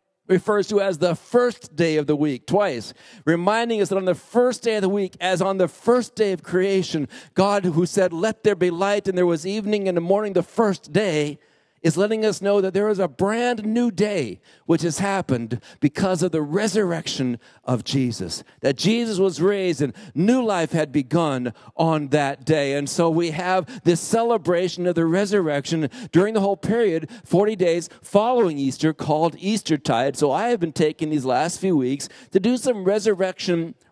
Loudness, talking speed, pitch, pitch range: -22 LUFS, 190 wpm, 185 Hz, 160-205 Hz